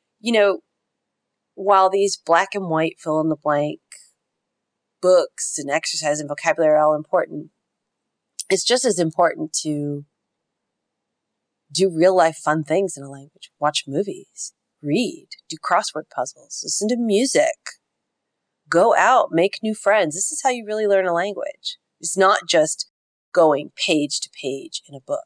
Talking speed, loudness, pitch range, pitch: 150 wpm, -20 LUFS, 155-220 Hz, 180 Hz